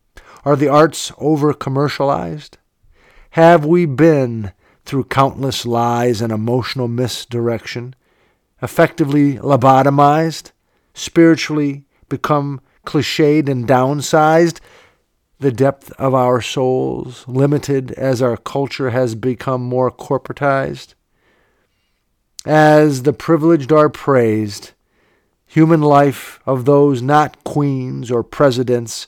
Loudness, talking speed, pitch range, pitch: -15 LUFS, 95 wpm, 125-150 Hz, 135 Hz